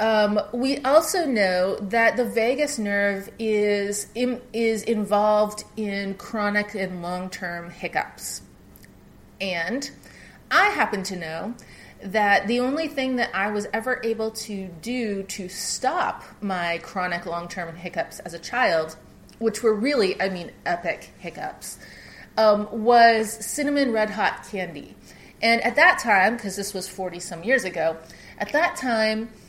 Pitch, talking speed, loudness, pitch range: 210 Hz, 140 wpm, -23 LUFS, 190-230 Hz